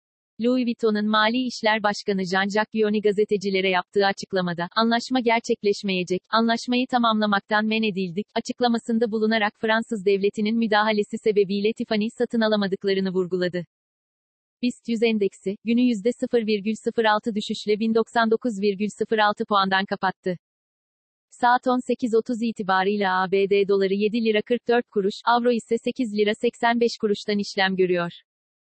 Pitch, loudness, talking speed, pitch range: 215 Hz, -23 LUFS, 110 wpm, 200-230 Hz